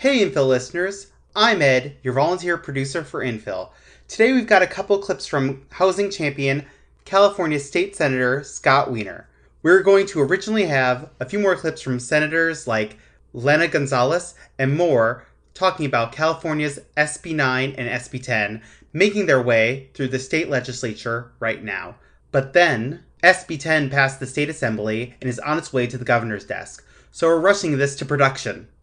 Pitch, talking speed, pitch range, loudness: 140 Hz, 165 wpm, 125-170 Hz, -20 LUFS